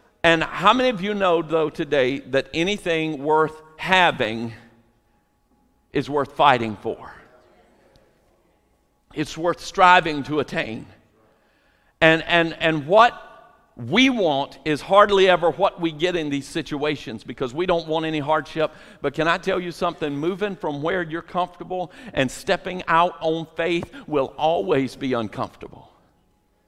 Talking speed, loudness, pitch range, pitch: 140 wpm, -21 LUFS, 145-180 Hz, 160 Hz